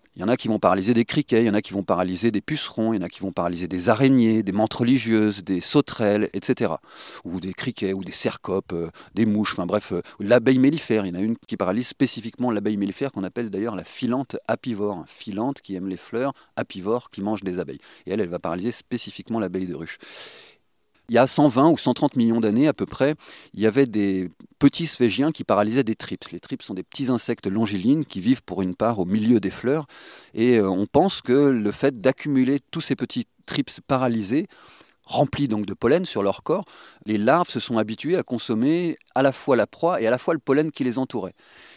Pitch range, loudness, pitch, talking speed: 100-135 Hz, -23 LUFS, 115 Hz, 225 wpm